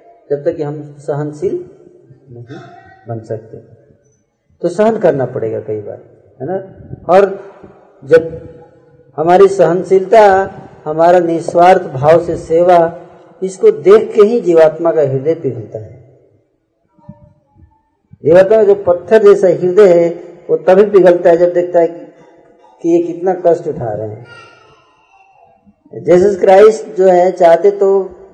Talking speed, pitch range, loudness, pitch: 130 wpm, 160-195 Hz, -11 LUFS, 175 Hz